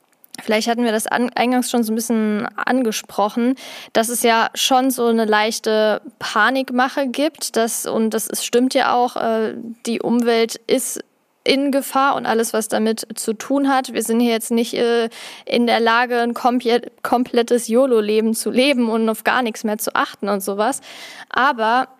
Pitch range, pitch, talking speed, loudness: 225-255 Hz, 235 Hz, 165 wpm, -18 LUFS